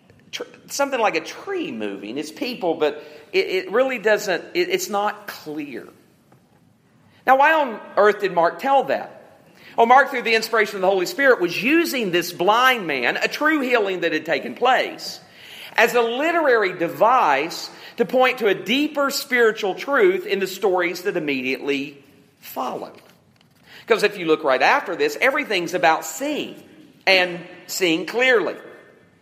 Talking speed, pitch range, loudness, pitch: 155 wpm, 175-270 Hz, -20 LUFS, 215 Hz